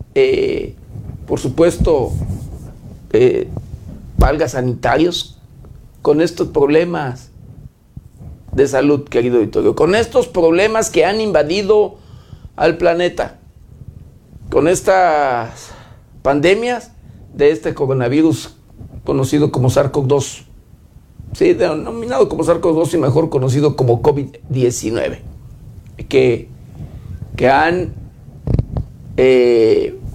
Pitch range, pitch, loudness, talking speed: 125-175 Hz, 145 Hz, -15 LUFS, 85 wpm